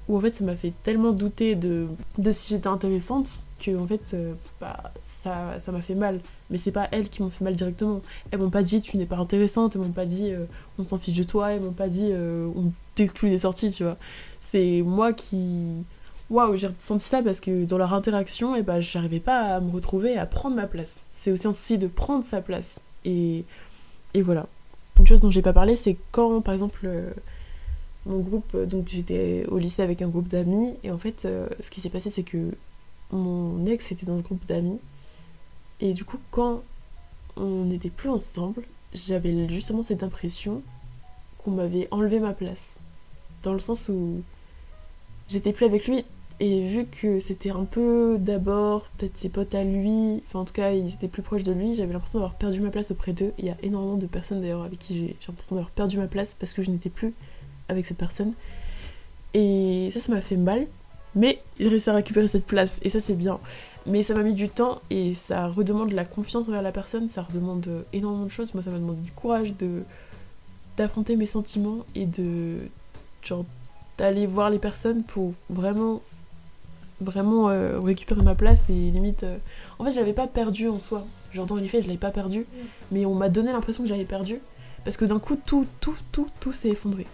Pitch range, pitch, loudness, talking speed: 175-210 Hz, 195 Hz, -26 LUFS, 215 wpm